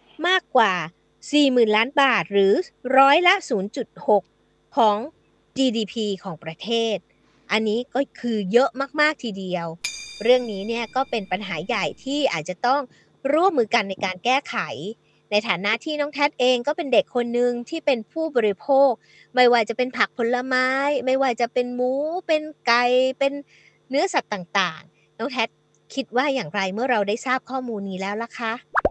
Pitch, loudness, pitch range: 245 Hz, -22 LUFS, 210-270 Hz